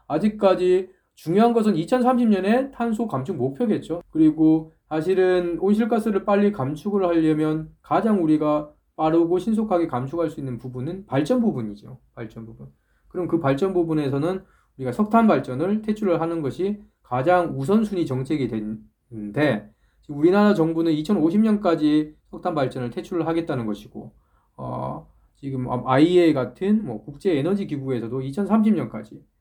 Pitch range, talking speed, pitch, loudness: 130-195 Hz, 310 characters per minute, 160 Hz, -22 LUFS